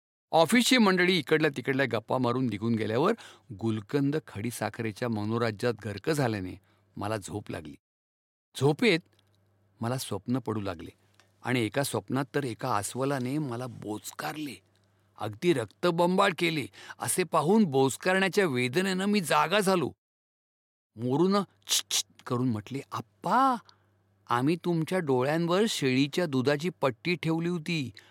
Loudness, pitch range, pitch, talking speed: -28 LUFS, 110-165 Hz, 130 Hz, 110 wpm